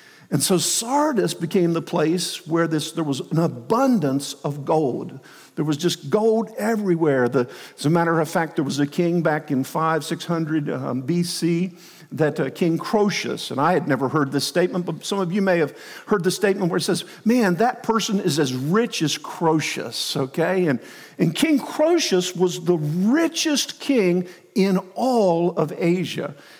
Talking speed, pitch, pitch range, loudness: 180 wpm, 175 Hz, 160-200 Hz, -22 LUFS